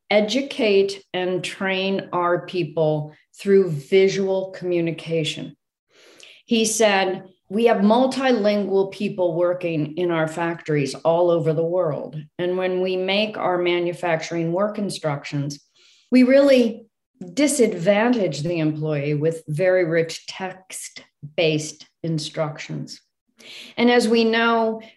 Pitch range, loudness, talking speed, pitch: 165-210 Hz, -21 LUFS, 110 wpm, 185 Hz